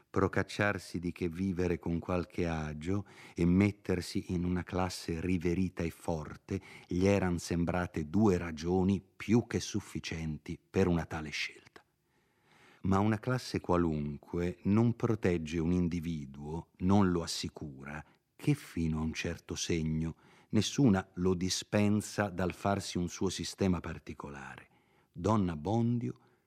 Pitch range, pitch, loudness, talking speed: 85-100 Hz, 90 Hz, -33 LUFS, 125 wpm